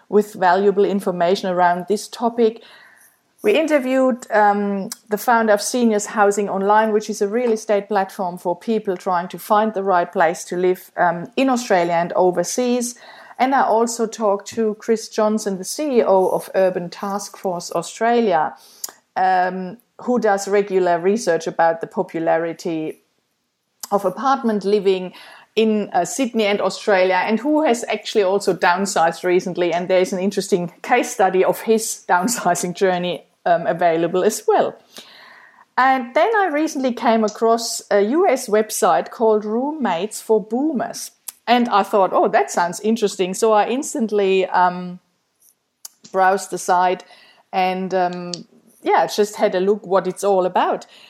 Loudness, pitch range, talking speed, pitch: -19 LUFS, 185-225 Hz, 150 wpm, 205 Hz